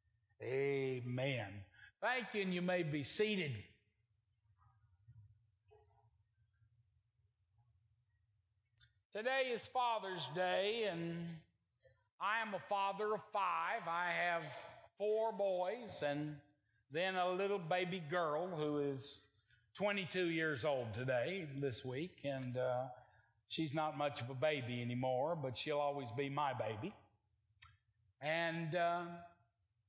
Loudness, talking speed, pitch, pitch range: -40 LUFS, 110 wpm, 140 Hz, 110-175 Hz